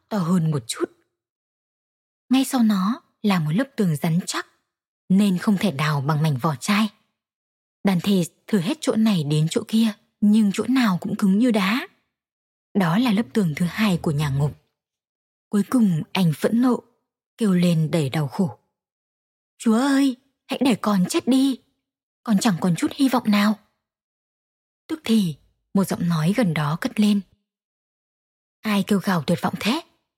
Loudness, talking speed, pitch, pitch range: -22 LUFS, 170 wpm, 205 Hz, 175-230 Hz